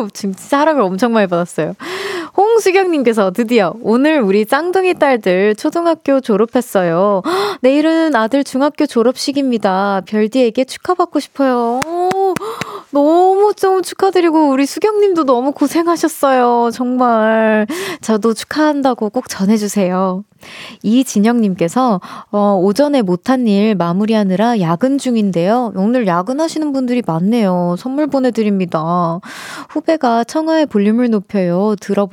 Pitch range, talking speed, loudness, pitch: 205-305 Hz, 300 characters per minute, -14 LUFS, 245 Hz